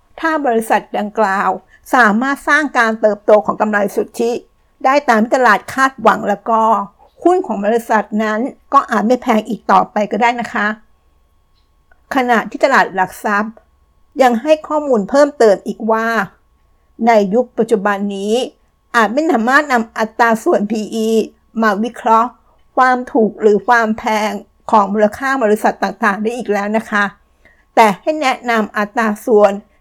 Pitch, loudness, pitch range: 225 Hz, -14 LUFS, 210-245 Hz